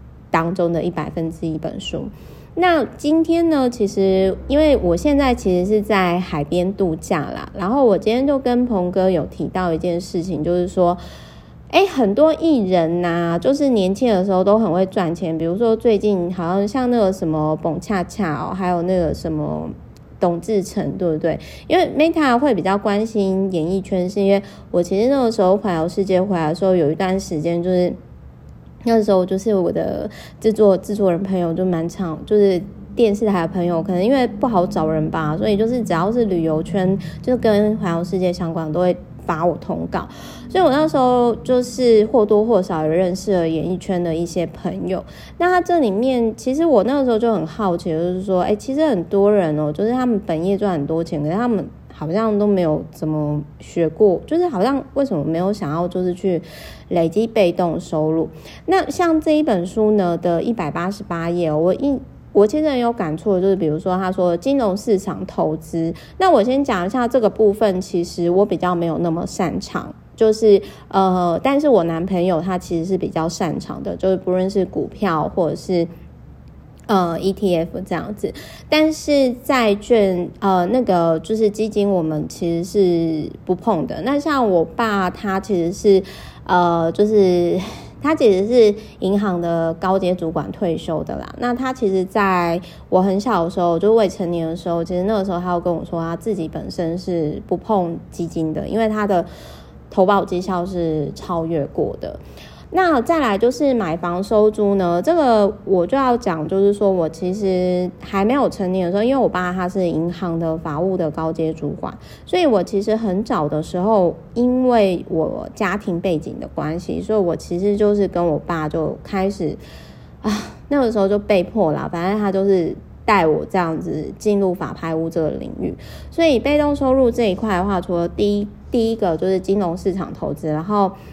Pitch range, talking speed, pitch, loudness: 170-215 Hz, 280 characters per minute, 185 Hz, -19 LUFS